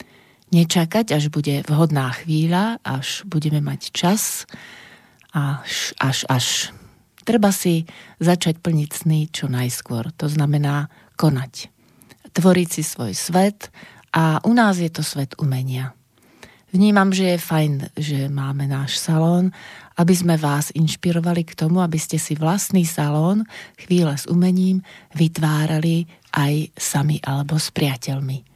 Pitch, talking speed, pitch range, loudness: 160 Hz, 130 wpm, 145-175 Hz, -20 LUFS